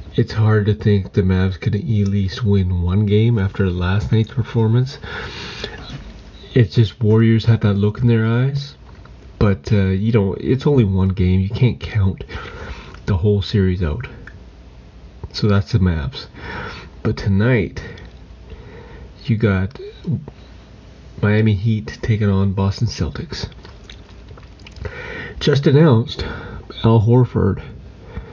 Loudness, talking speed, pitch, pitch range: -18 LUFS, 125 wpm, 105 Hz, 95-115 Hz